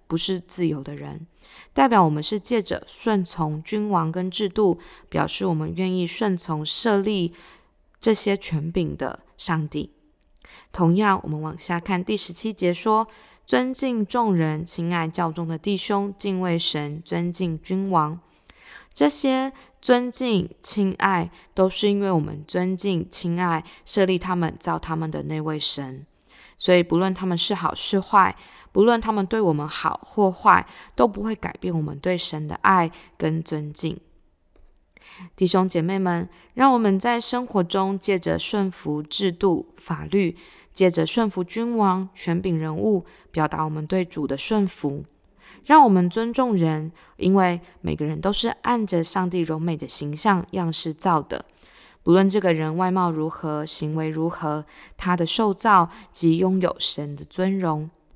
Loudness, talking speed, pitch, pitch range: -23 LUFS, 225 characters per minute, 180 Hz, 160-200 Hz